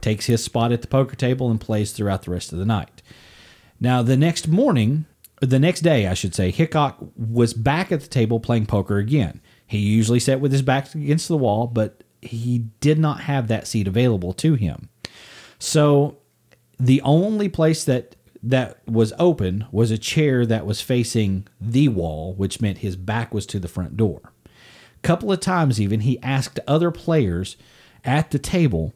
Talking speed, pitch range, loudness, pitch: 190 wpm, 105-145 Hz, -21 LUFS, 120 Hz